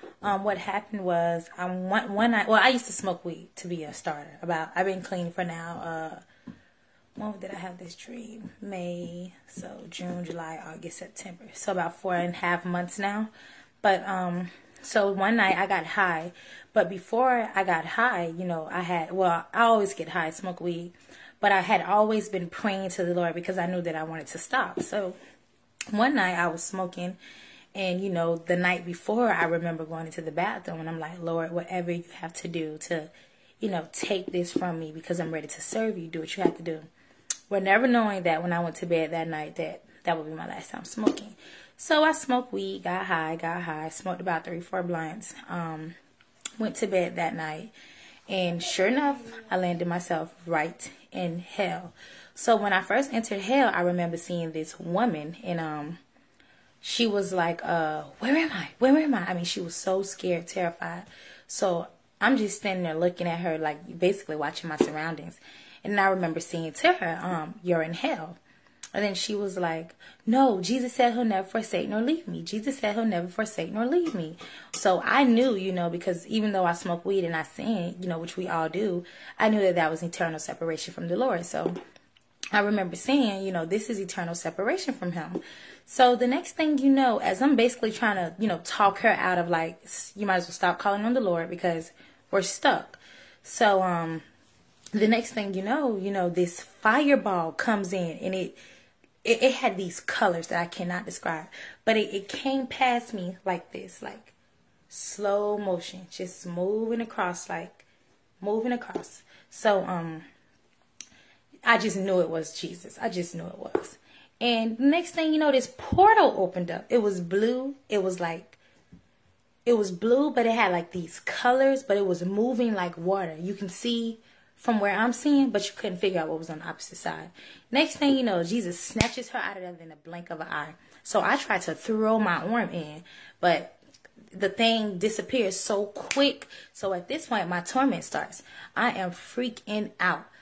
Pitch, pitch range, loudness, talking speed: 185 Hz, 170-220 Hz, -27 LUFS, 200 wpm